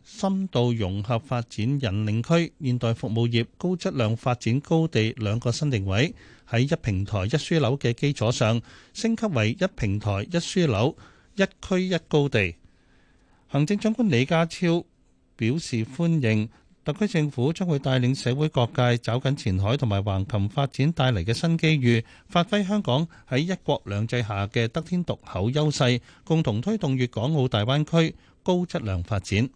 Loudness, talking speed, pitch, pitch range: -25 LUFS, 250 characters per minute, 125 Hz, 110-160 Hz